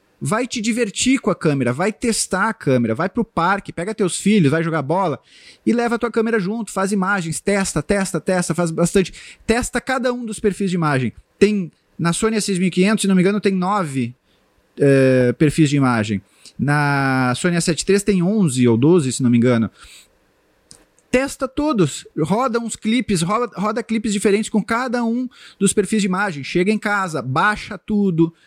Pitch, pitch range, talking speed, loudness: 195 Hz, 160-220 Hz, 180 wpm, -19 LUFS